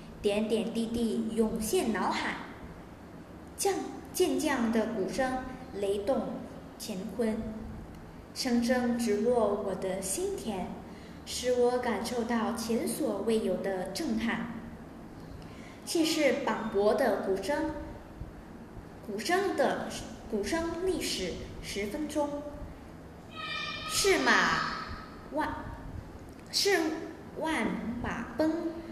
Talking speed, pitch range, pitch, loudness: 130 characters per minute, 220-300 Hz, 240 Hz, -31 LUFS